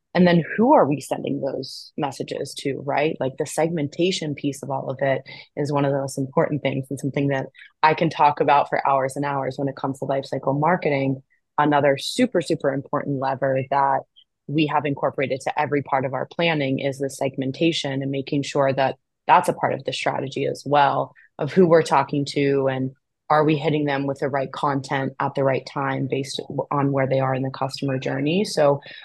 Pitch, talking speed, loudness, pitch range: 140 Hz, 205 wpm, -22 LUFS, 135-150 Hz